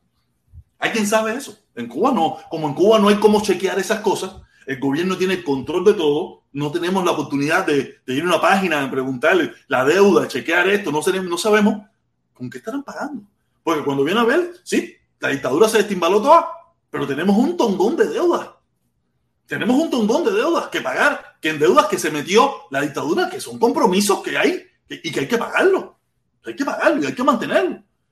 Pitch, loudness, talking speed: 205 Hz, -18 LUFS, 200 wpm